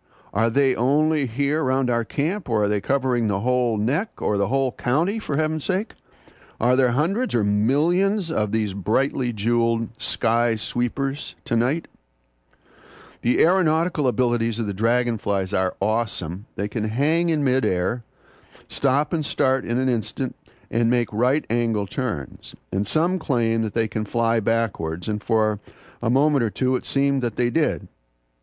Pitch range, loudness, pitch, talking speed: 110-140 Hz, -23 LUFS, 120 Hz, 160 wpm